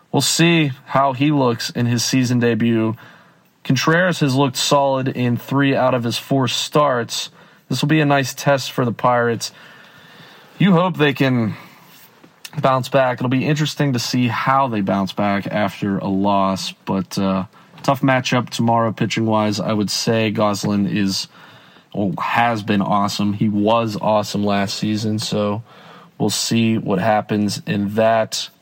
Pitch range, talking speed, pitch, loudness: 105-140 Hz, 155 wpm, 120 Hz, -18 LUFS